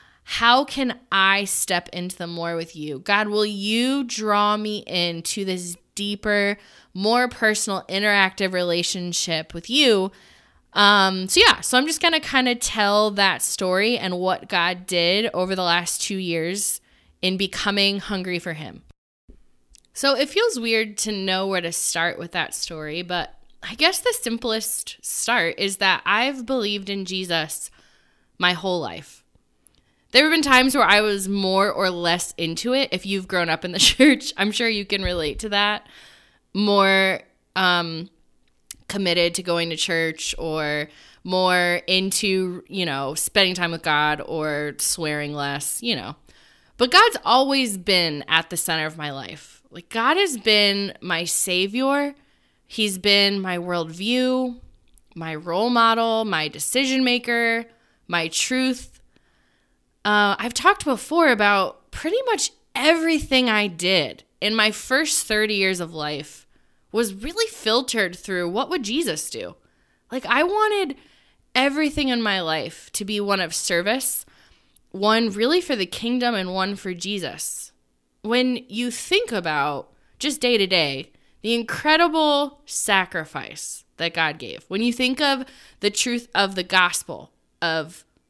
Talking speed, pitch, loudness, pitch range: 150 wpm, 200 Hz, -21 LUFS, 175-240 Hz